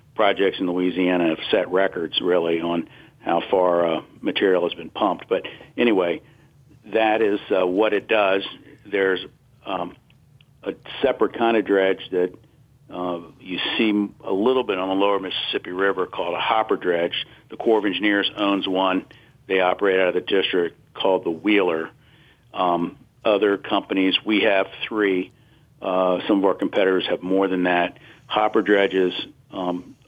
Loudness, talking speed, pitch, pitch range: -22 LUFS, 160 wpm, 95 Hz, 90-105 Hz